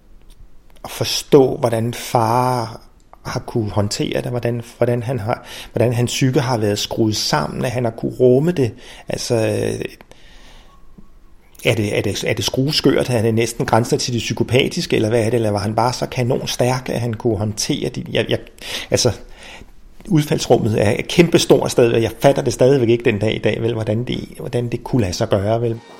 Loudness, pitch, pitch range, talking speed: -18 LUFS, 120 Hz, 115-130 Hz, 190 wpm